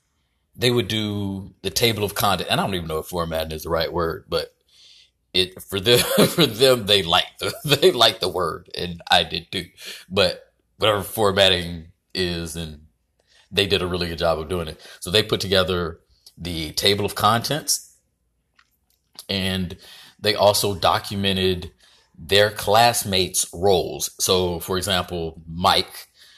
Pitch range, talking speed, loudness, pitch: 85-105 Hz, 155 wpm, -21 LUFS, 95 Hz